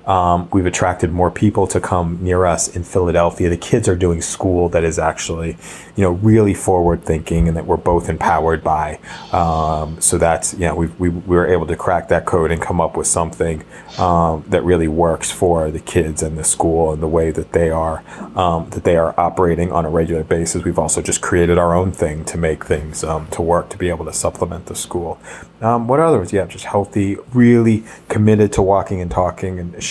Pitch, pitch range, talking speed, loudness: 85 Hz, 80-90 Hz, 215 wpm, -17 LUFS